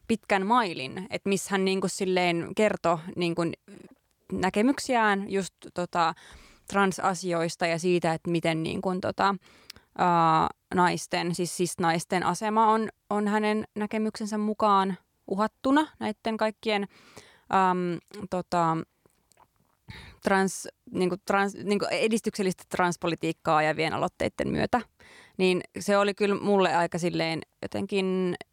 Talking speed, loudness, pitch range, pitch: 115 wpm, -27 LUFS, 175-205 Hz, 190 Hz